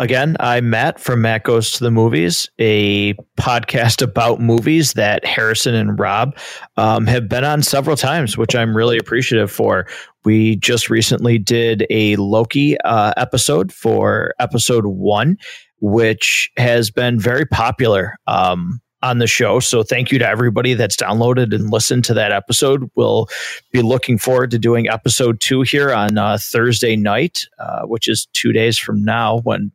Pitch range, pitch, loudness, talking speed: 110-125 Hz, 115 Hz, -15 LUFS, 165 wpm